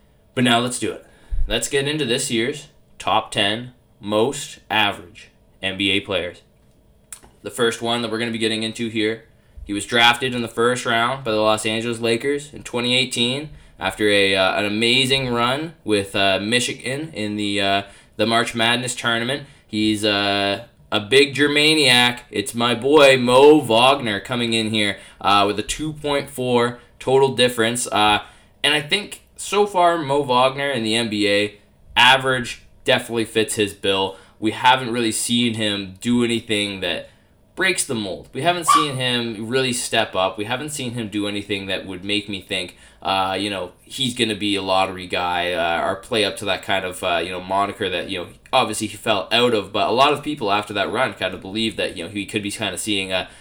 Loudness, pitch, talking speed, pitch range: -19 LUFS, 110 Hz, 195 wpm, 100-125 Hz